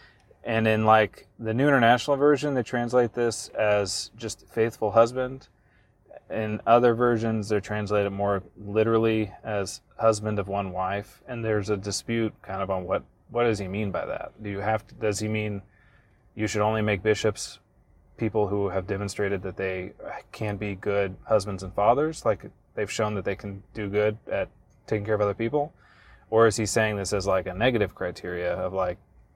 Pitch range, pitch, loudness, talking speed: 100-115 Hz, 105 Hz, -26 LUFS, 185 wpm